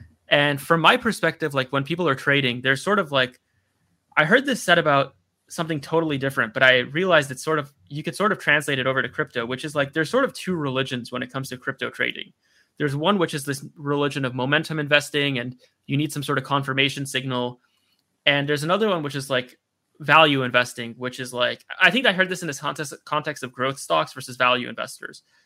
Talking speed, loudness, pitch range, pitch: 220 wpm, -22 LUFS, 130-155 Hz, 140 Hz